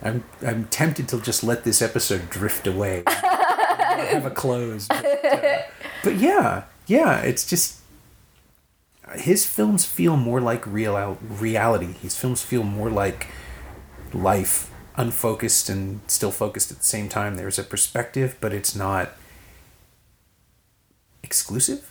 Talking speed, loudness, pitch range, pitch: 130 wpm, -22 LUFS, 95-120 Hz, 105 Hz